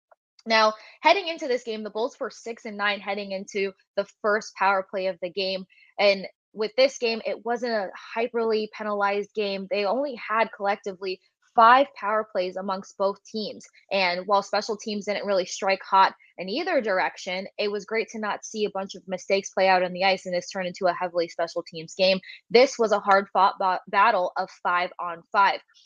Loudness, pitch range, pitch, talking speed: -25 LUFS, 190-220 Hz, 200 Hz, 200 wpm